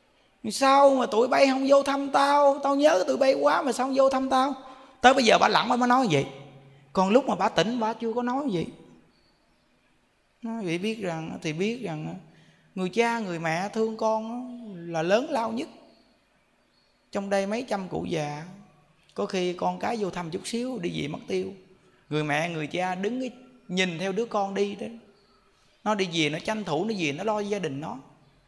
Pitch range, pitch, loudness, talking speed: 175-245 Hz, 210 Hz, -25 LUFS, 210 wpm